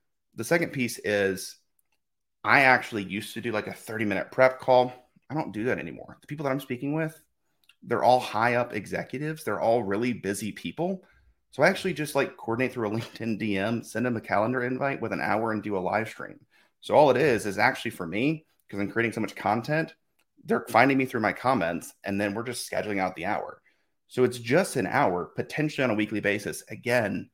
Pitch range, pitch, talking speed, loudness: 105-135 Hz, 120 Hz, 215 wpm, -27 LUFS